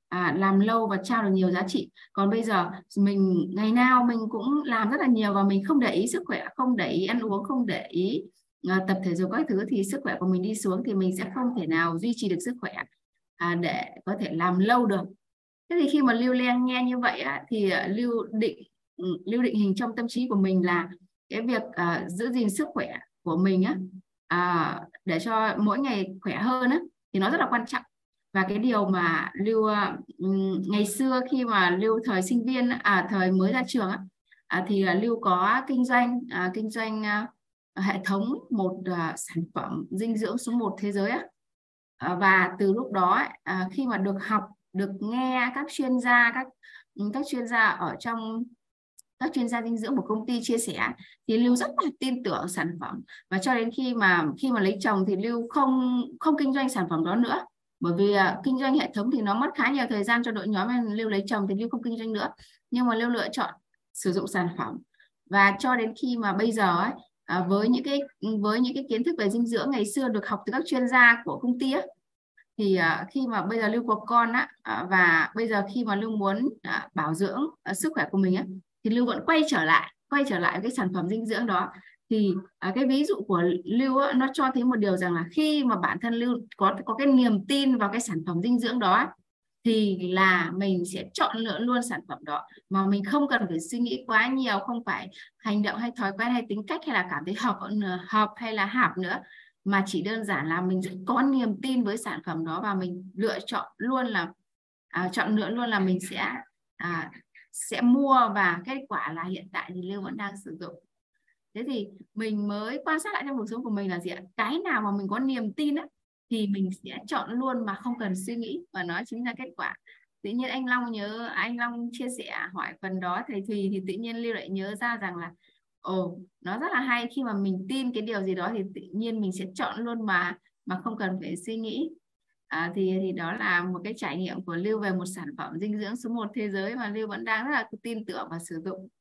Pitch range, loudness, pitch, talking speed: 190-245 Hz, -27 LUFS, 215 Hz, 235 wpm